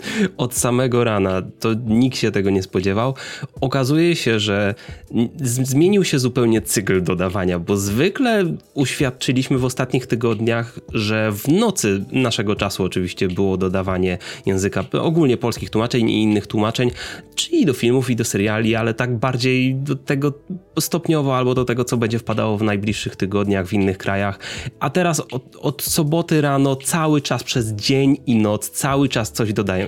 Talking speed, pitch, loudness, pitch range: 160 wpm, 120 Hz, -19 LUFS, 105-135 Hz